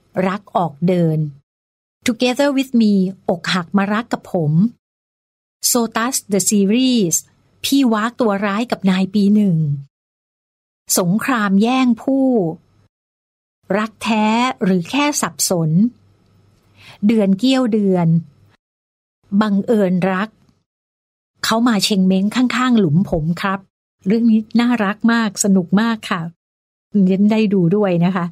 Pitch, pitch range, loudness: 200 Hz, 170-225 Hz, -17 LUFS